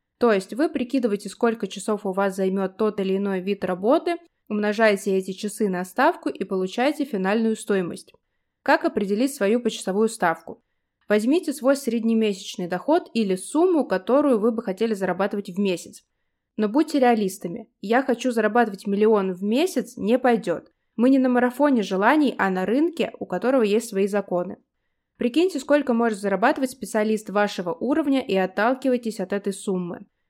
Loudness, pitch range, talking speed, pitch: -23 LUFS, 195-255 Hz, 150 wpm, 220 Hz